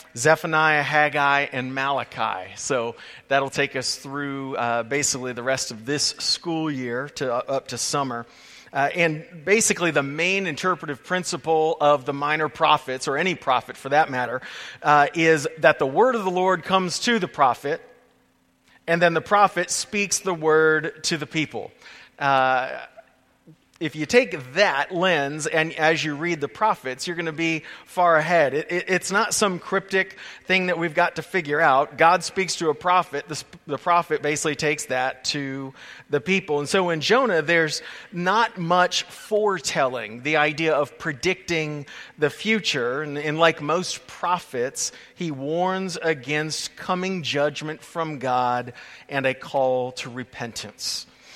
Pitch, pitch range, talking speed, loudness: 155 Hz, 140-175 Hz, 160 wpm, -22 LUFS